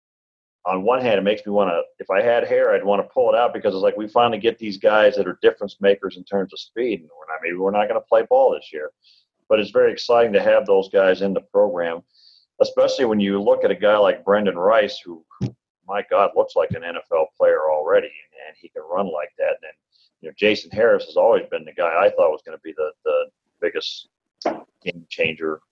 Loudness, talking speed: -20 LUFS, 235 wpm